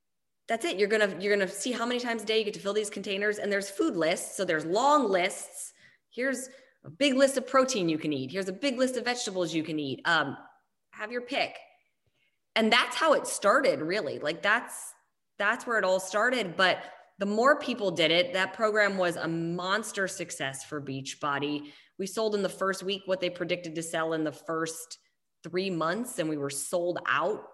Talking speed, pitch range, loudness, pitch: 215 wpm, 165-225 Hz, -28 LUFS, 195 Hz